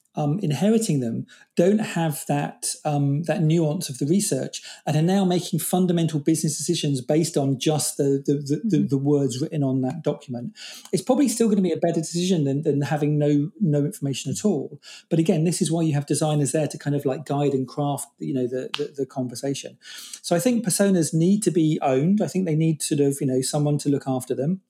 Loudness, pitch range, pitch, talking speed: -23 LUFS, 145-175 Hz, 155 Hz, 225 wpm